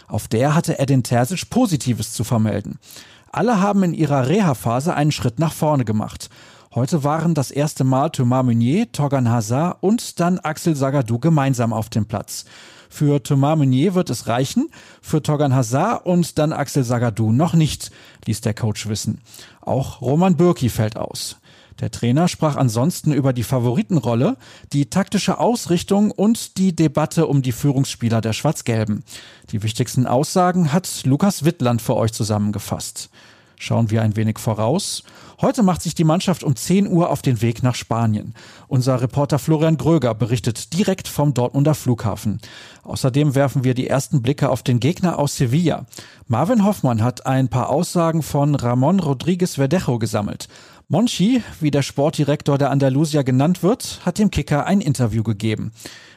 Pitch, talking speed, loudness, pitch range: 140 Hz, 160 wpm, -19 LUFS, 120-165 Hz